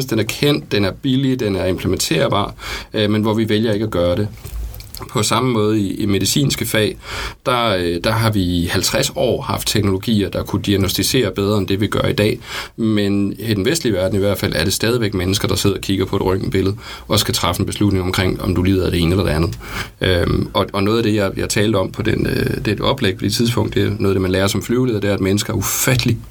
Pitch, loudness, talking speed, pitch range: 105 Hz, -17 LUFS, 260 wpm, 95-115 Hz